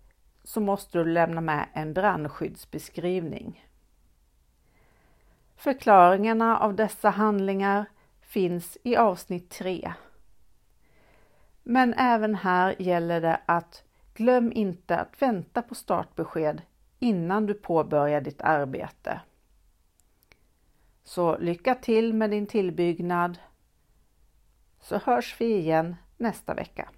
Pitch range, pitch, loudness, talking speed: 160-215 Hz, 180 Hz, -26 LUFS, 100 wpm